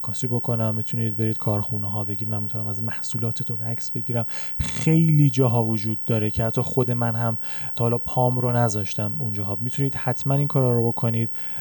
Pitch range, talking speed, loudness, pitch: 110-125 Hz, 175 wpm, -21 LUFS, 115 Hz